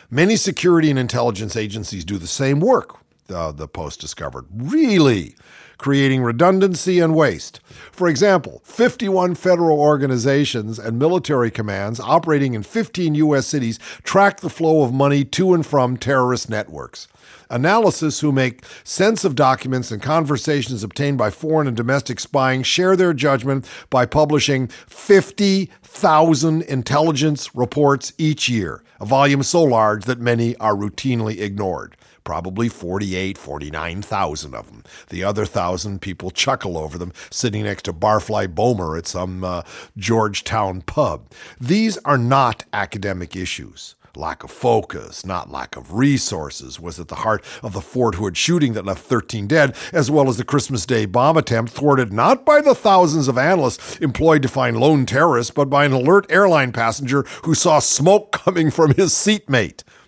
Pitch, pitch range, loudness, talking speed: 130 Hz, 105-155 Hz, -18 LUFS, 155 wpm